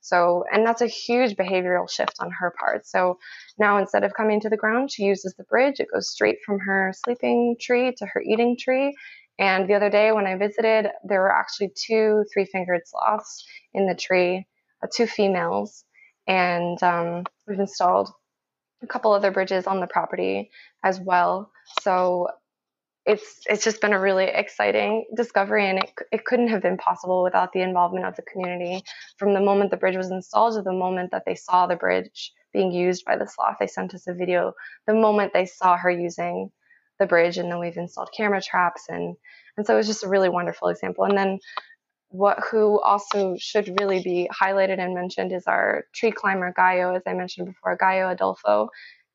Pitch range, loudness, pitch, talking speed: 180-215 Hz, -23 LUFS, 190 Hz, 195 wpm